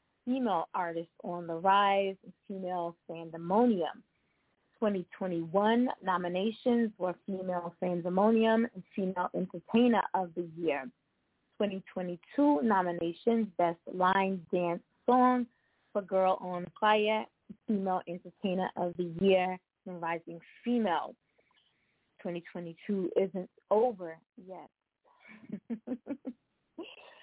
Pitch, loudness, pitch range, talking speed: 190 Hz, -31 LUFS, 175-225 Hz, 85 wpm